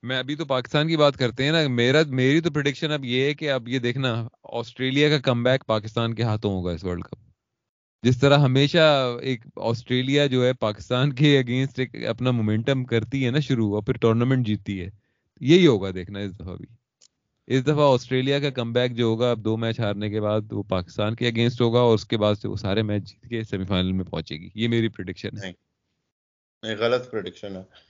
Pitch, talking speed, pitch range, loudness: 120 Hz, 215 wpm, 105-130 Hz, -23 LUFS